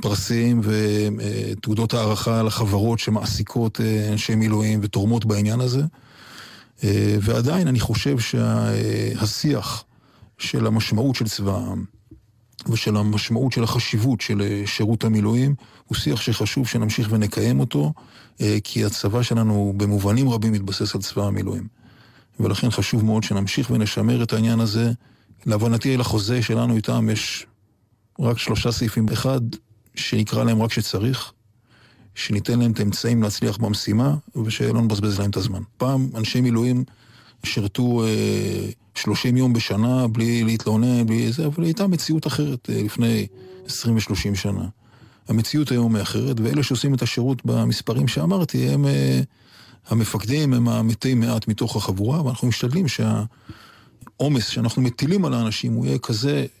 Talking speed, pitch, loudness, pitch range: 130 wpm, 115 Hz, -21 LUFS, 105-125 Hz